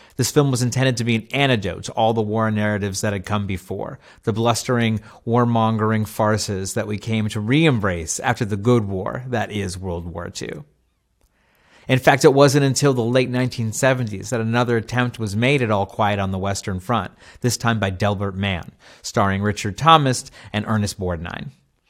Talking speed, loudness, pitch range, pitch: 180 wpm, -20 LUFS, 100-125 Hz, 110 Hz